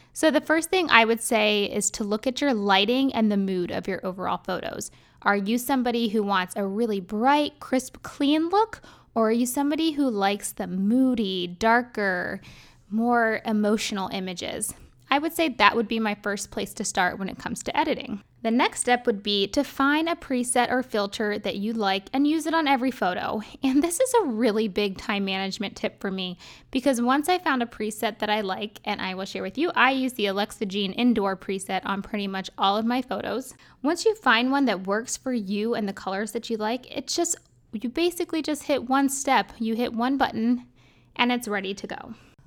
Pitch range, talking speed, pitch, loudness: 205-265 Hz, 210 wpm, 225 Hz, -25 LUFS